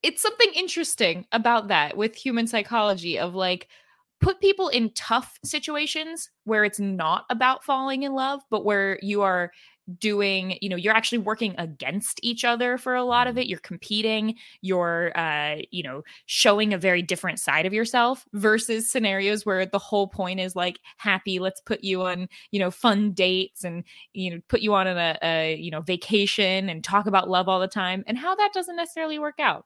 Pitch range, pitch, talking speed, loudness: 185-240 Hz, 205 Hz, 190 wpm, -24 LUFS